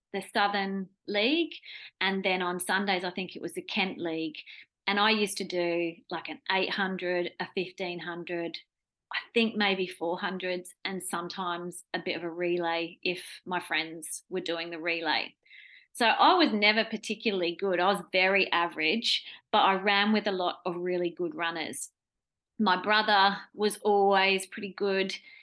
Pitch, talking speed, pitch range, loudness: 185 Hz, 160 wpm, 175-205 Hz, -28 LUFS